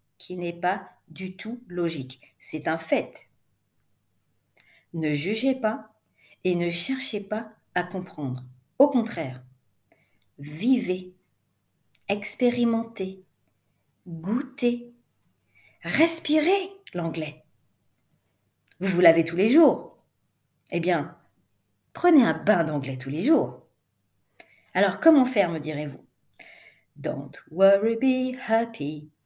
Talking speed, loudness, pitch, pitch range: 100 wpm, -25 LUFS, 180 Hz, 150-230 Hz